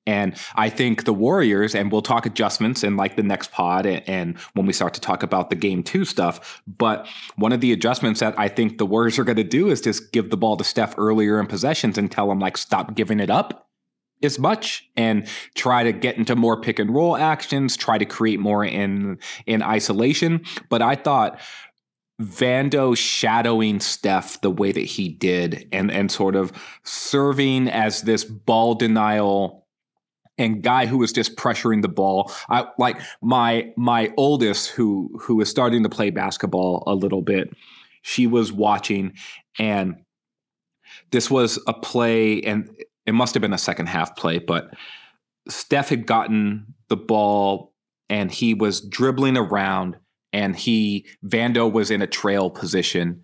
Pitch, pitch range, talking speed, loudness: 110 Hz, 100-120 Hz, 175 wpm, -21 LUFS